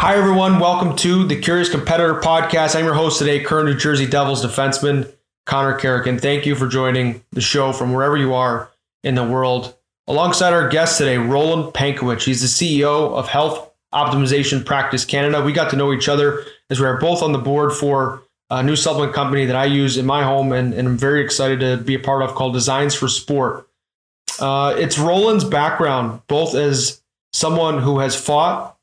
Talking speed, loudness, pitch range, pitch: 200 wpm, -17 LUFS, 130-155 Hz, 140 Hz